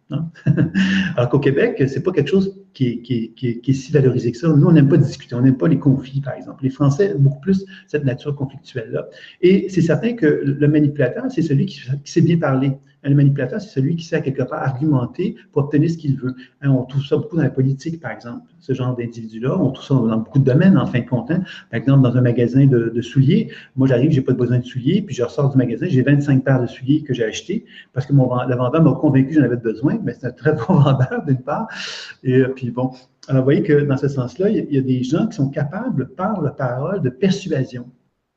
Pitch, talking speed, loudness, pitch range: 140 Hz, 265 wpm, -18 LUFS, 130-155 Hz